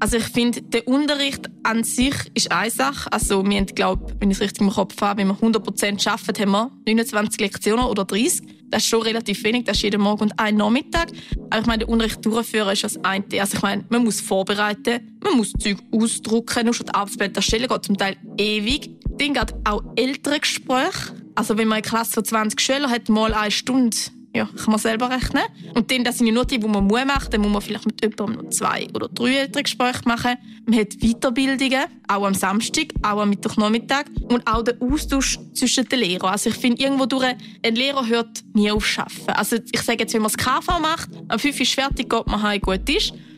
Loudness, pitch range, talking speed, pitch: -21 LUFS, 210-250 Hz, 230 wpm, 225 Hz